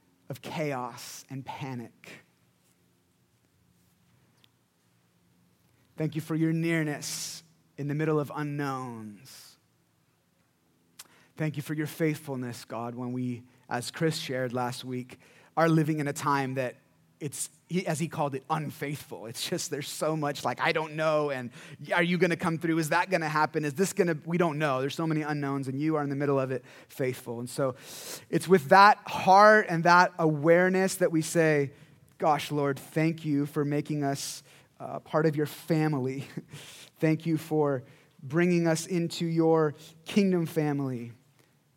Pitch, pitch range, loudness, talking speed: 150 Hz, 135-160 Hz, -28 LUFS, 160 wpm